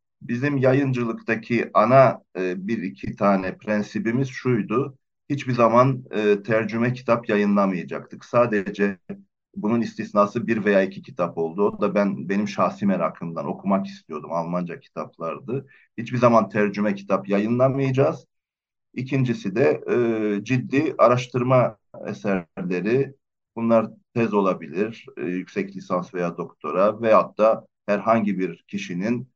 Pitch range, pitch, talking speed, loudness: 100-125 Hz, 110 Hz, 115 wpm, -23 LUFS